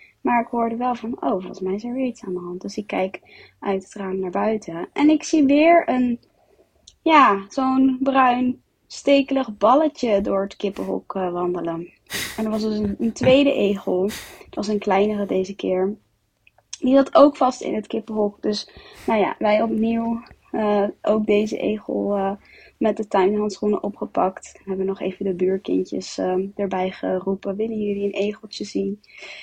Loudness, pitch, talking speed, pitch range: -21 LUFS, 210 Hz, 175 wpm, 195-240 Hz